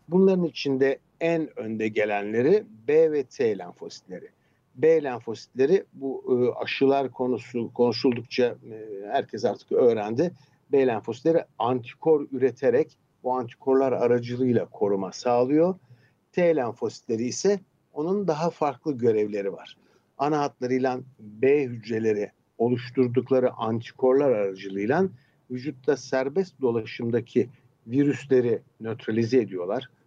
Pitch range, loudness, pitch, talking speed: 120-155 Hz, -25 LUFS, 130 Hz, 95 wpm